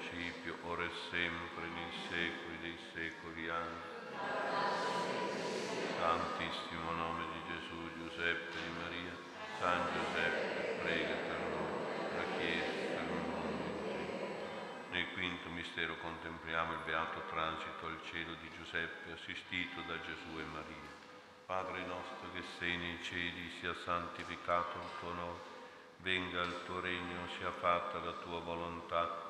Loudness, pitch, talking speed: -40 LUFS, 85 Hz, 120 wpm